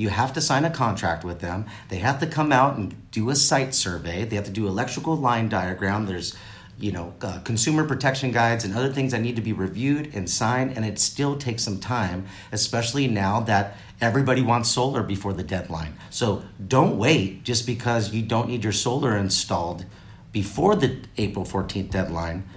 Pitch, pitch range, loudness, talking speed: 110 Hz, 95-125 Hz, -24 LUFS, 195 wpm